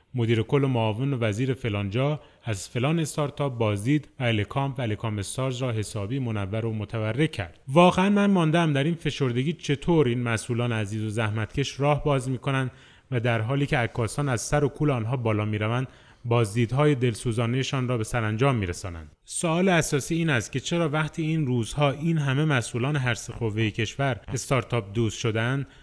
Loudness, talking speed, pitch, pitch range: -26 LUFS, 165 wpm, 130 Hz, 115-145 Hz